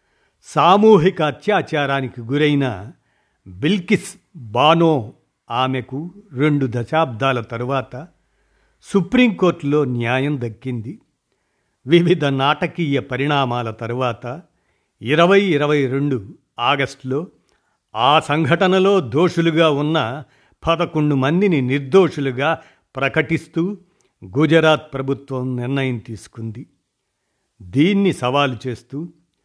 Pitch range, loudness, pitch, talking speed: 130-165 Hz, -18 LUFS, 145 Hz, 70 wpm